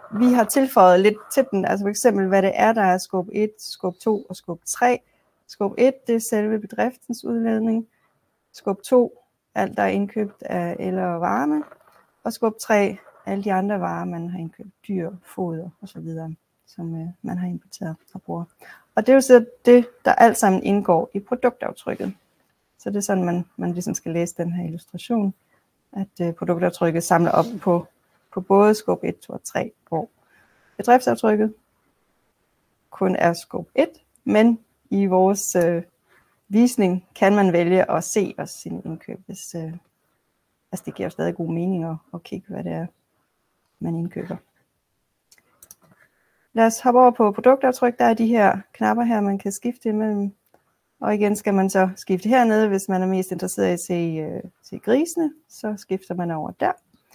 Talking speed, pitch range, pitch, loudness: 175 wpm, 175-225 Hz, 200 Hz, -21 LUFS